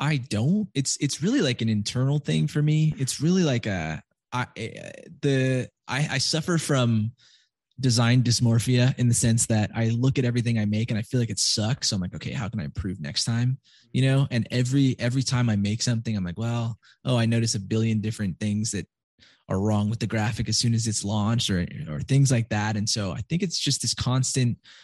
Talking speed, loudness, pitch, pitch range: 220 wpm, -25 LUFS, 120 Hz, 110-135 Hz